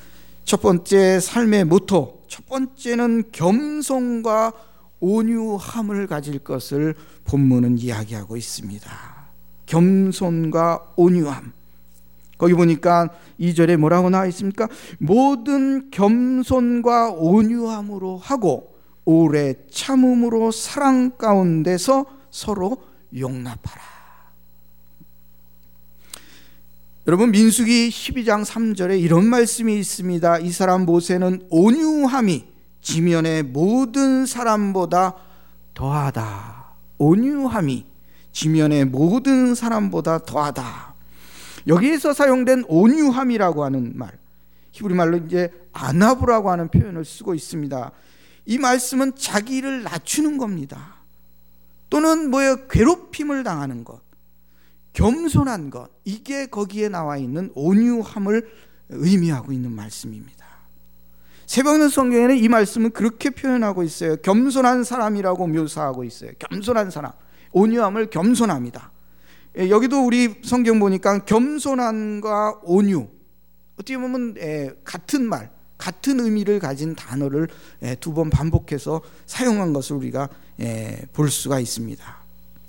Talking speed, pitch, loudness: 245 characters per minute, 180 Hz, -19 LUFS